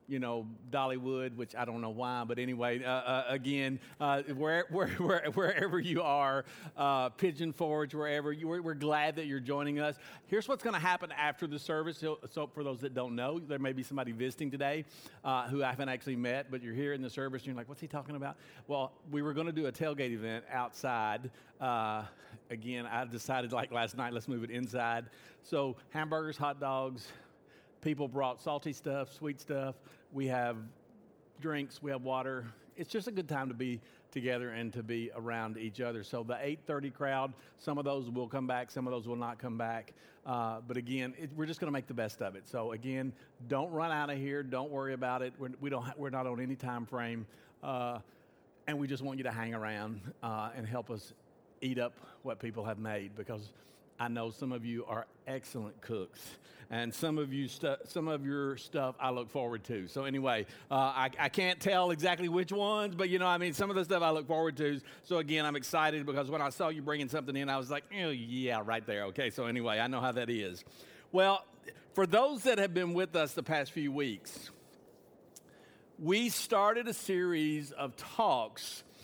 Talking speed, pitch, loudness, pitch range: 215 wpm, 135 Hz, -36 LUFS, 120-150 Hz